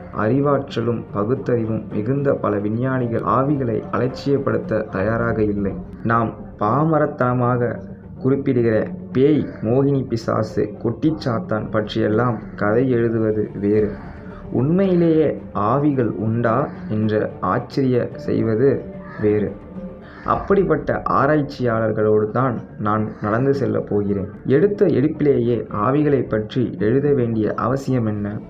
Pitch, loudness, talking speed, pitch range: 115 Hz, -20 LUFS, 90 wpm, 105-135 Hz